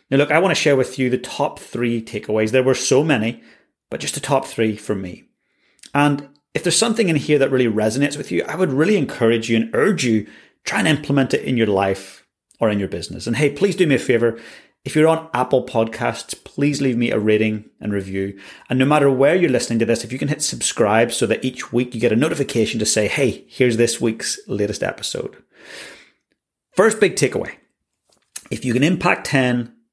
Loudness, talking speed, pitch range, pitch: -19 LUFS, 220 wpm, 115-145 Hz, 125 Hz